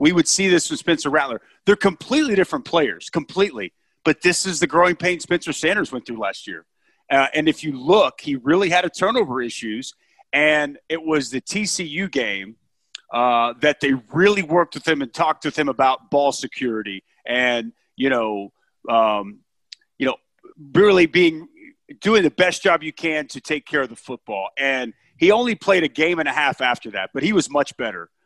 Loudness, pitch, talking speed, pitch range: -20 LUFS, 155 Hz, 195 wpm, 135-190 Hz